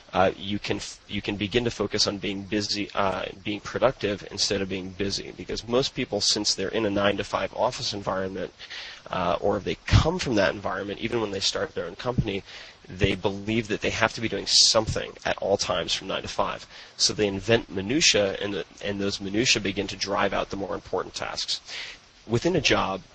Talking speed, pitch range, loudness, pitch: 210 wpm, 100-110 Hz, -25 LUFS, 100 Hz